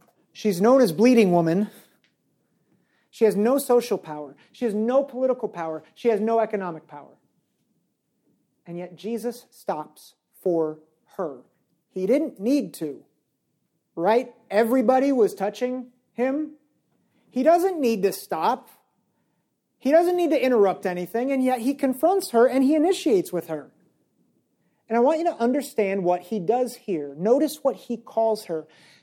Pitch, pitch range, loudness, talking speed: 230 Hz, 190-260 Hz, -23 LUFS, 145 wpm